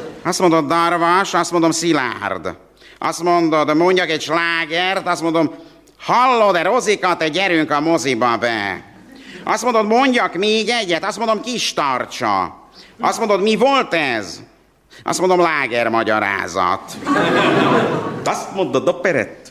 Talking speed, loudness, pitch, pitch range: 130 wpm, -17 LUFS, 175 Hz, 165-210 Hz